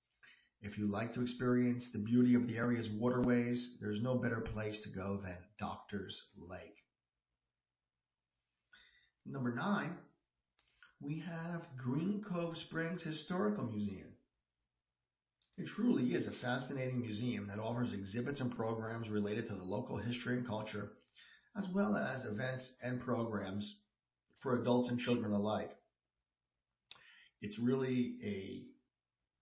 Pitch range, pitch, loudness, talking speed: 100-125 Hz, 115 Hz, -39 LUFS, 125 wpm